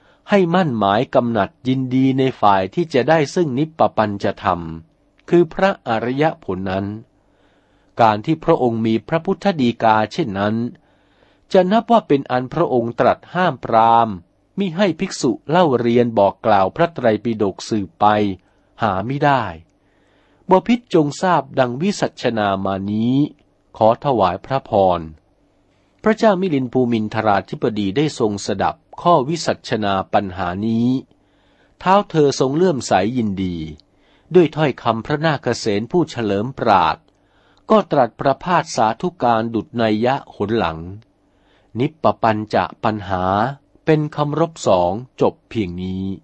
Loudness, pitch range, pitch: -18 LUFS, 100-160 Hz, 120 Hz